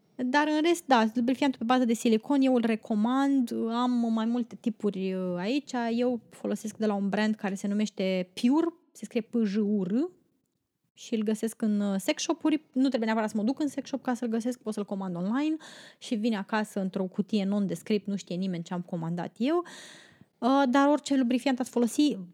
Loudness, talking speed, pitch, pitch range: -28 LUFS, 195 wpm, 230 Hz, 205-260 Hz